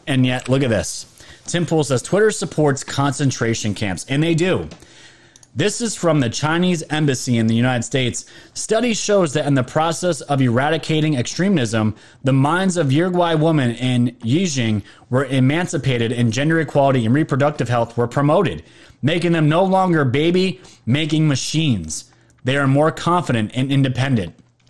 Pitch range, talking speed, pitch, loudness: 120-165 Hz, 155 wpm, 140 Hz, -18 LUFS